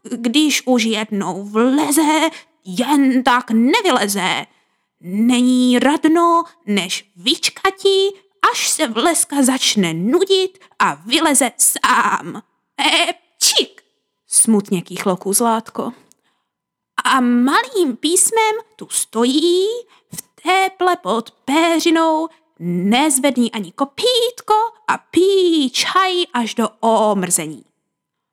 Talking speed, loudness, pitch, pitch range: 85 wpm, -16 LUFS, 295 Hz, 230-355 Hz